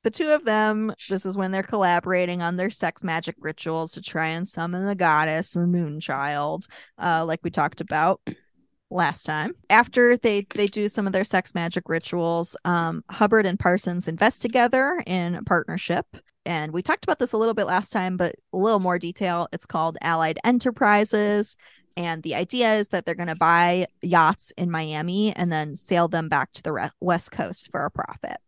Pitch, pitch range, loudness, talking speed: 180 Hz, 165-210 Hz, -23 LUFS, 195 wpm